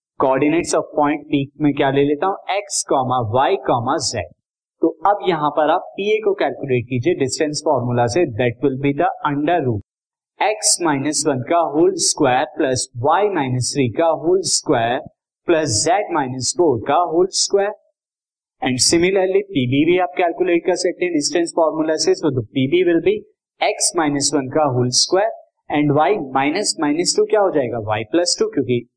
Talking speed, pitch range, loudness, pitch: 120 wpm, 135-190 Hz, -18 LUFS, 155 Hz